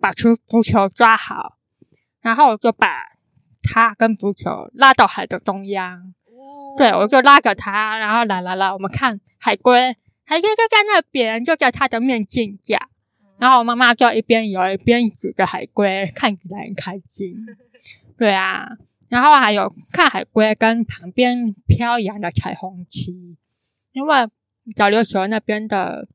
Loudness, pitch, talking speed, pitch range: -16 LUFS, 225 Hz, 220 characters per minute, 200-250 Hz